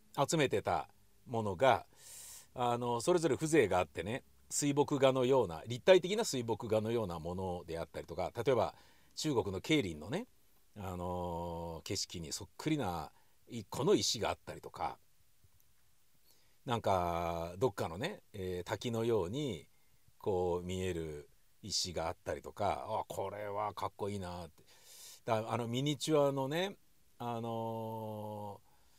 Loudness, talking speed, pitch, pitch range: -36 LUFS, 275 characters per minute, 110 Hz, 90-130 Hz